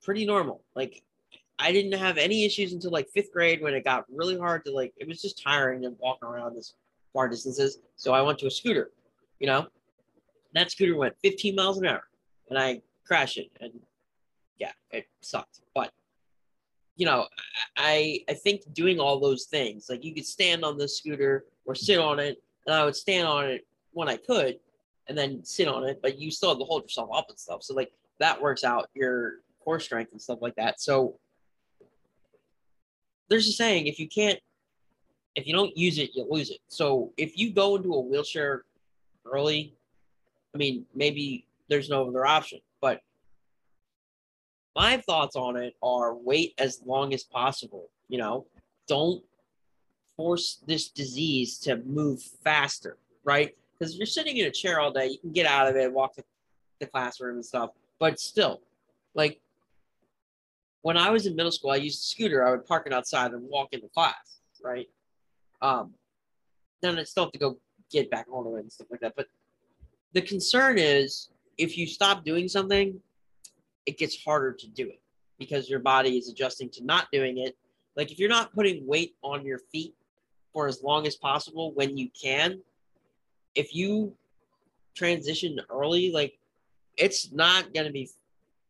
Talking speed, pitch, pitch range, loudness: 185 wpm, 145 Hz, 130-175 Hz, -27 LUFS